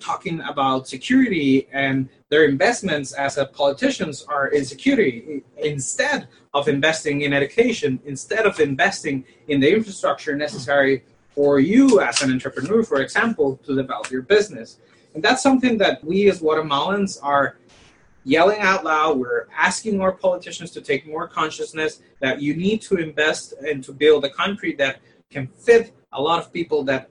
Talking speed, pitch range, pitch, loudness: 160 wpm, 140-190 Hz, 150 Hz, -20 LUFS